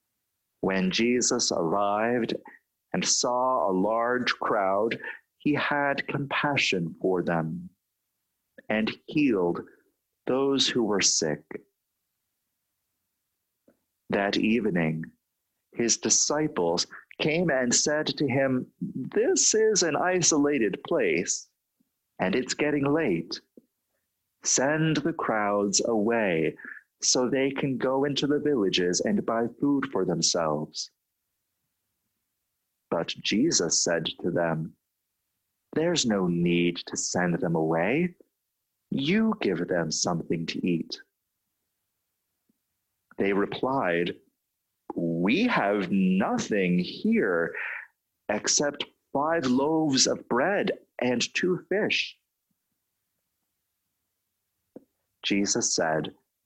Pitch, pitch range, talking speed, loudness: 110 Hz, 90-145 Hz, 90 wpm, -26 LUFS